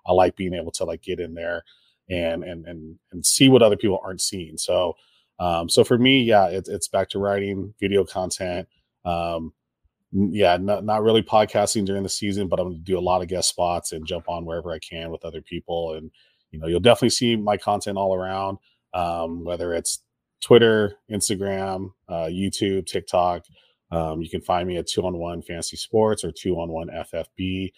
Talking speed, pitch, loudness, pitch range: 200 wpm, 90 Hz, -22 LUFS, 85-100 Hz